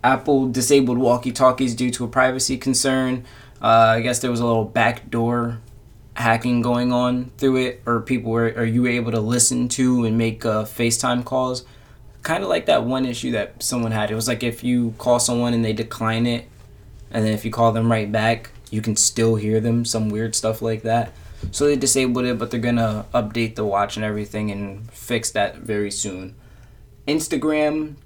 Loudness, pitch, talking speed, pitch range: -20 LUFS, 120 Hz, 200 wpm, 110-125 Hz